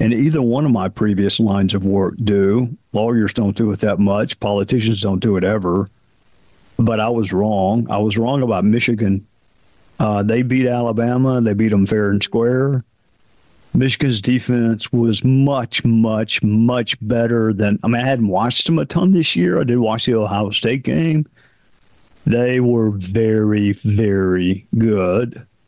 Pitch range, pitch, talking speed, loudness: 105-120 Hz, 115 Hz, 165 wpm, -17 LUFS